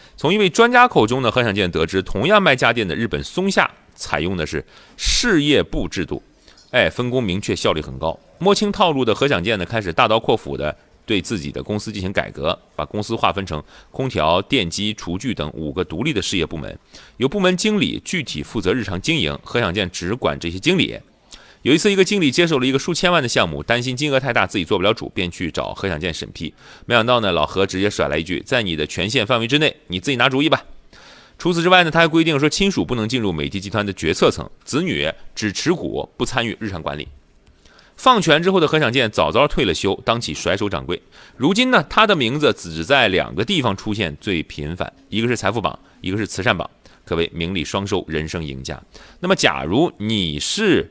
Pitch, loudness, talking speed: 105 Hz, -19 LUFS, 330 characters per minute